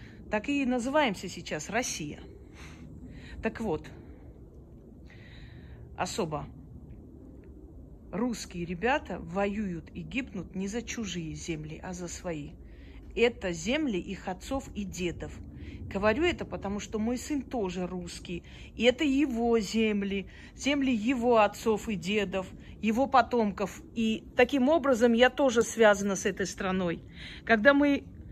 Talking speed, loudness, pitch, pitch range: 120 wpm, -29 LUFS, 205 Hz, 175-245 Hz